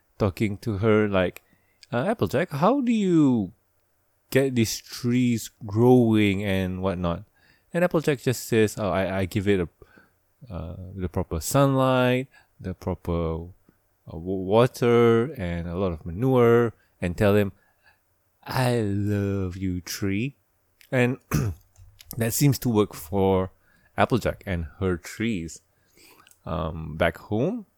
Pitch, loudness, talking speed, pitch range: 100 Hz, -24 LUFS, 125 wpm, 95-120 Hz